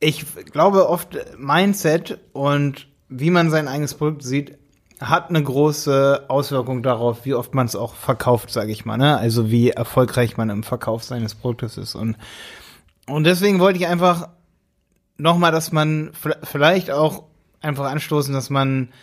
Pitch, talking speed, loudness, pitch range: 140 Hz, 160 wpm, -19 LUFS, 120-155 Hz